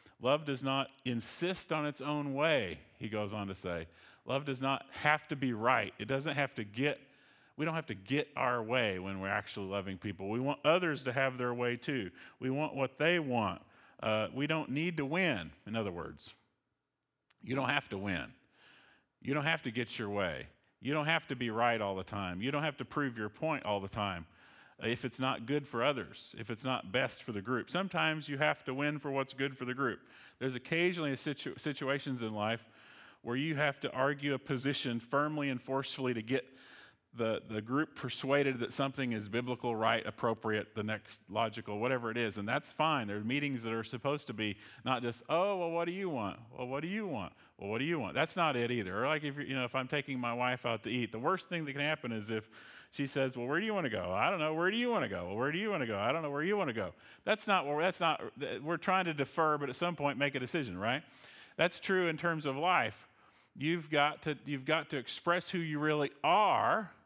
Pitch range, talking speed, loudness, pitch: 115-150 Hz, 240 wpm, -35 LUFS, 135 Hz